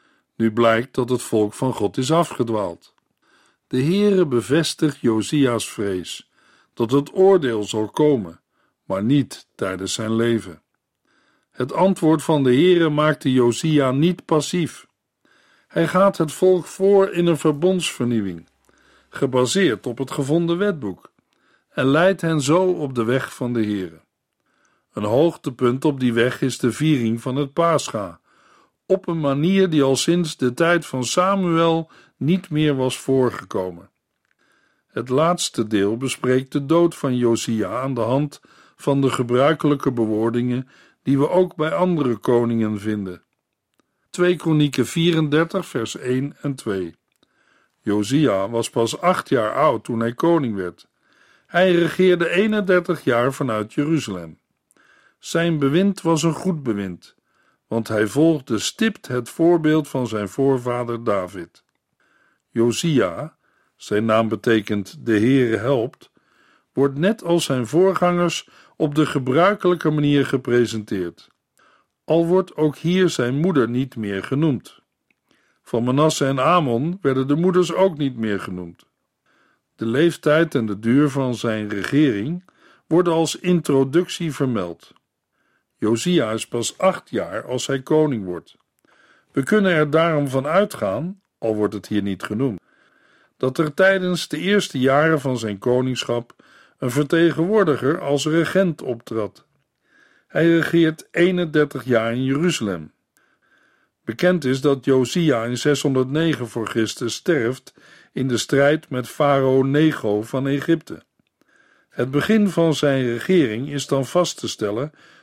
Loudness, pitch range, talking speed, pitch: -20 LUFS, 120-165 Hz, 135 wpm, 140 Hz